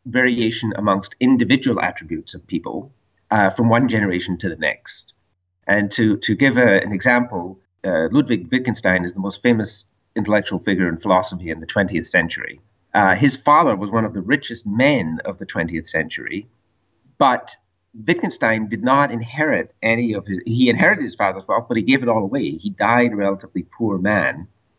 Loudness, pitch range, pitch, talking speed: -19 LUFS, 95-120 Hz, 105 Hz, 175 wpm